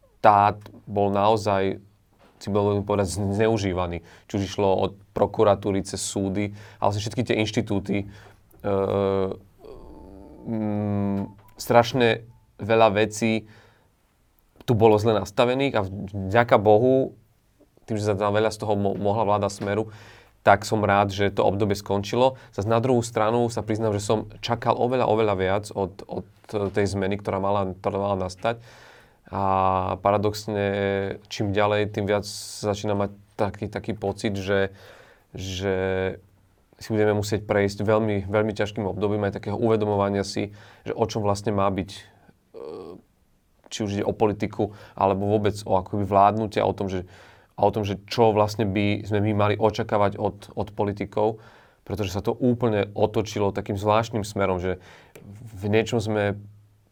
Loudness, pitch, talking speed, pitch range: -24 LUFS, 105 Hz, 145 wpm, 100-110 Hz